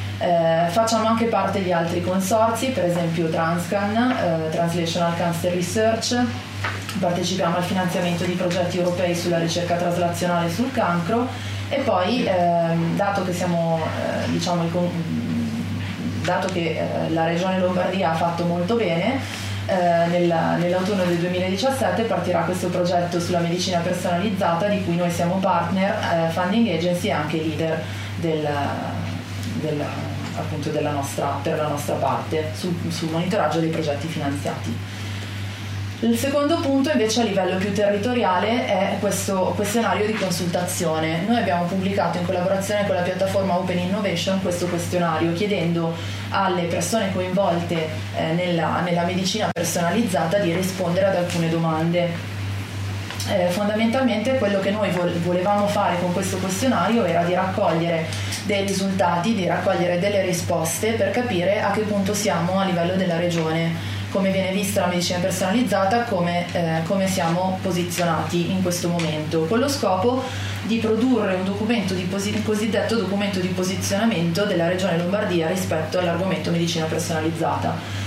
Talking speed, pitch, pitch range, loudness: 140 wpm, 175 Hz, 165-195 Hz, -22 LUFS